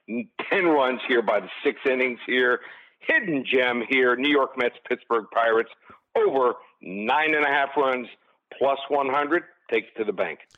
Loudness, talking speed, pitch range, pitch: -23 LUFS, 165 wpm, 125-145 Hz, 130 Hz